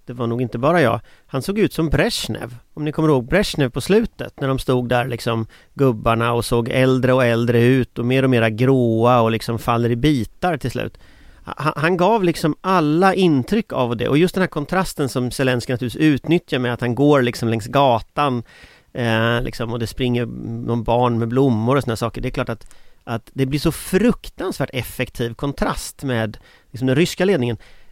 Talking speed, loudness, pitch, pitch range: 200 wpm, -19 LUFS, 125 Hz, 115-150 Hz